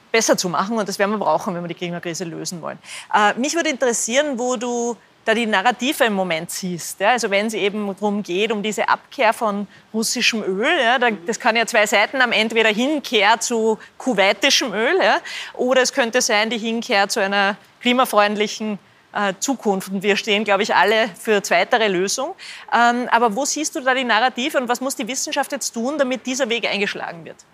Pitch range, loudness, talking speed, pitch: 205-250 Hz, -19 LUFS, 205 wpm, 225 Hz